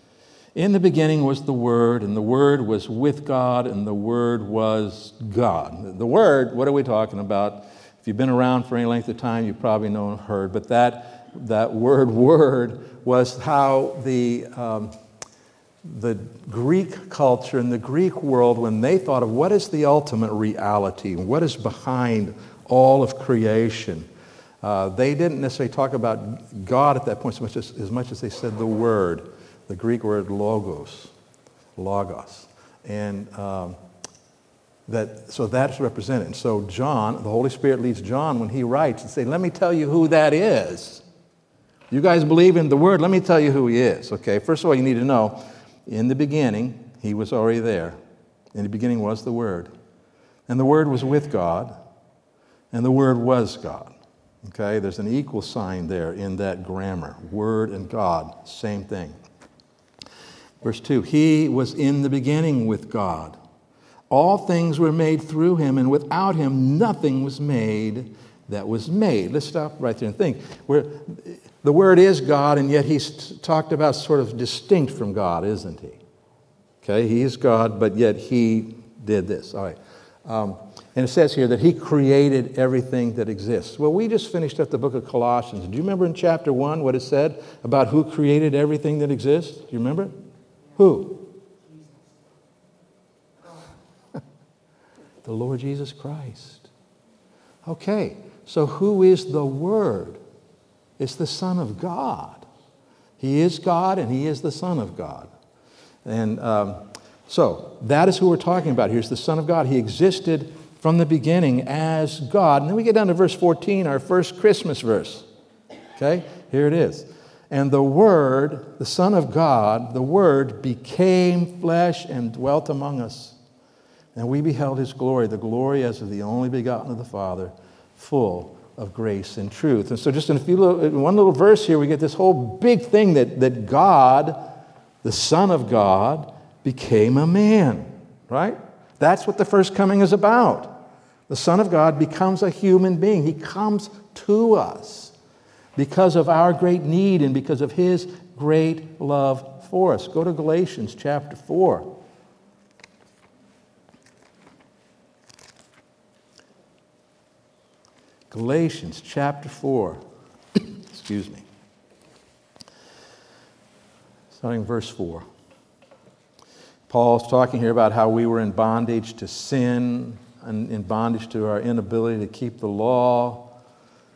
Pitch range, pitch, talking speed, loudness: 115-155 Hz, 130 Hz, 160 wpm, -20 LUFS